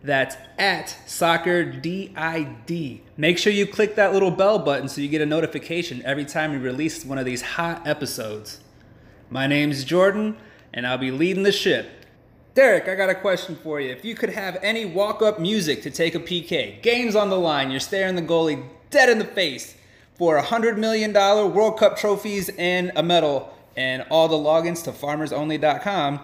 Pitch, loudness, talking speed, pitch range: 170 Hz, -22 LUFS, 190 wpm, 145-200 Hz